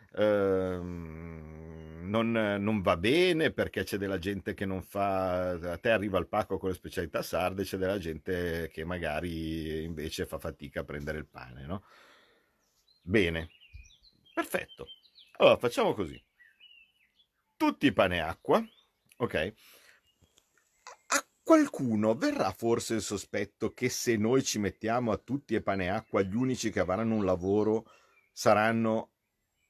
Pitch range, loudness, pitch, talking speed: 85-110 Hz, -30 LUFS, 95 Hz, 135 wpm